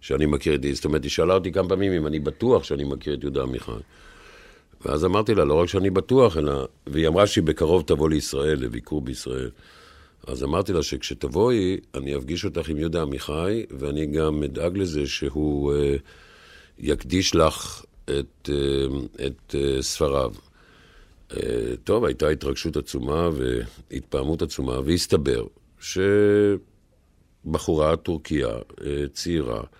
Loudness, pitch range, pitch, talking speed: -24 LUFS, 70-85 Hz, 75 Hz, 140 wpm